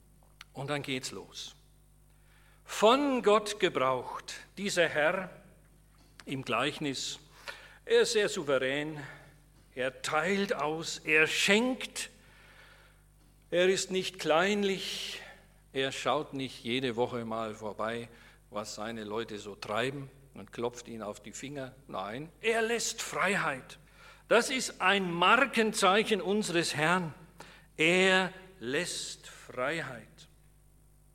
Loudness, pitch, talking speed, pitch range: -30 LUFS, 155 Hz, 105 wpm, 130-195 Hz